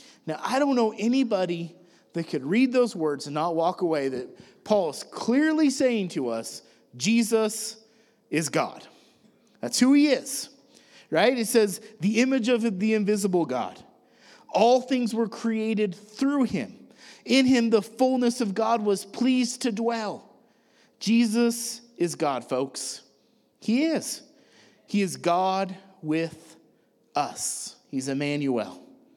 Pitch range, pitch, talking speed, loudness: 175-245 Hz, 220 Hz, 135 wpm, -25 LUFS